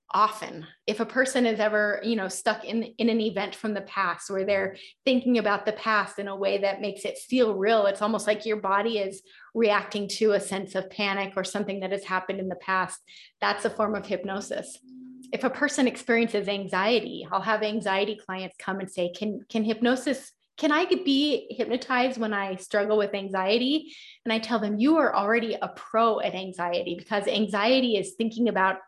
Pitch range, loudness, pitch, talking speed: 195-230 Hz, -26 LUFS, 210 Hz, 195 wpm